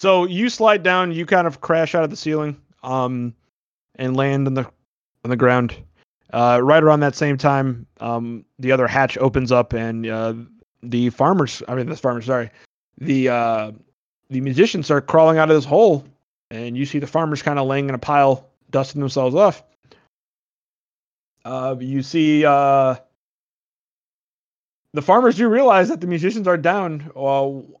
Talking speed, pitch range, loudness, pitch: 170 wpm, 125-155 Hz, -18 LUFS, 135 Hz